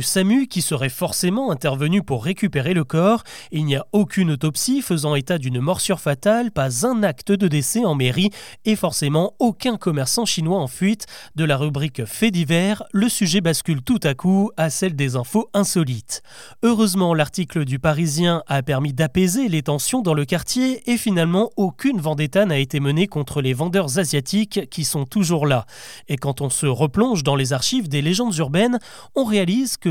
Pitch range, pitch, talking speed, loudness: 150-205 Hz, 175 Hz, 180 wpm, -20 LUFS